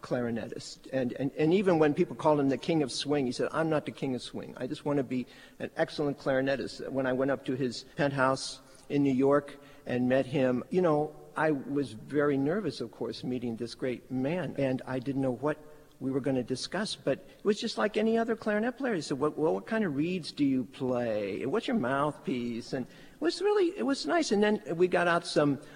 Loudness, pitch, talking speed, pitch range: -30 LUFS, 140 Hz, 235 wpm, 130-160 Hz